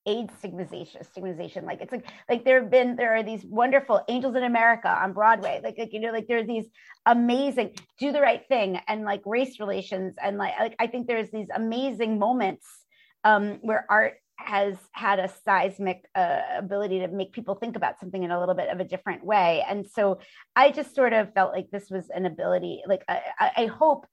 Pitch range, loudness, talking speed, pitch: 190-240 Hz, -25 LUFS, 210 wpm, 215 Hz